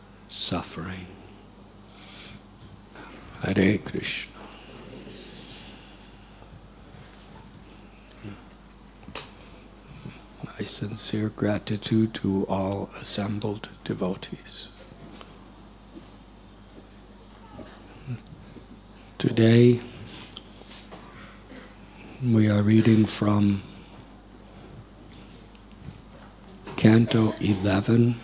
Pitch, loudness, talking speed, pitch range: 105 Hz, -24 LUFS, 35 wpm, 100-110 Hz